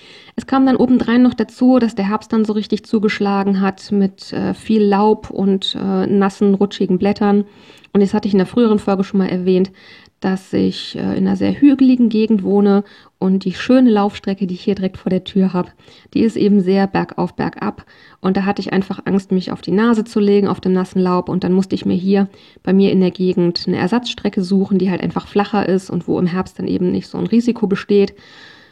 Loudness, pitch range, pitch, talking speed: -16 LUFS, 190-215 Hz, 200 Hz, 225 wpm